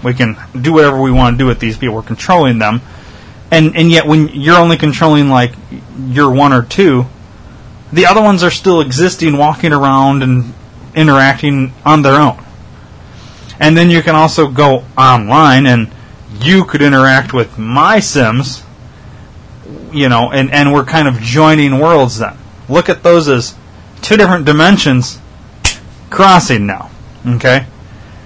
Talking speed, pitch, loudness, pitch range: 155 wpm, 135 Hz, -9 LUFS, 115-155 Hz